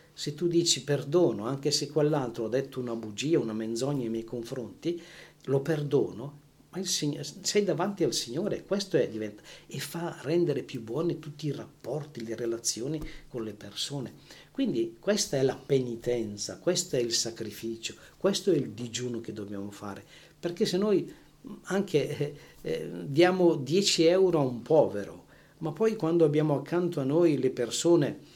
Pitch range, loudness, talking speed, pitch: 120-170 Hz, -29 LUFS, 165 wpm, 145 Hz